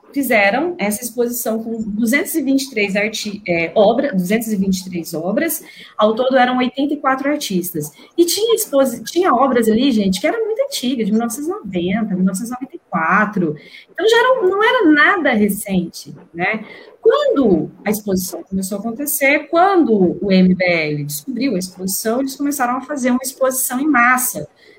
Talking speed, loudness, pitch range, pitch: 140 wpm, -16 LUFS, 200-290 Hz, 245 Hz